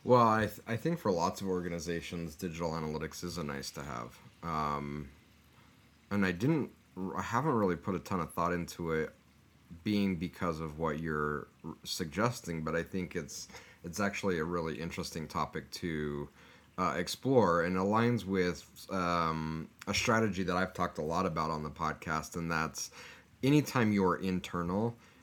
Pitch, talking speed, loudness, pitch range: 85 Hz, 165 wpm, -34 LUFS, 80-95 Hz